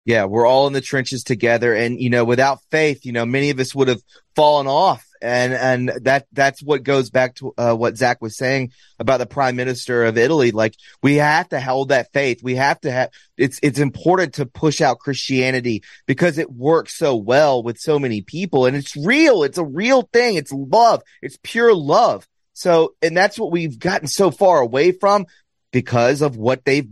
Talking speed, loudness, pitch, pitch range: 205 wpm, -17 LUFS, 135 Hz, 125-155 Hz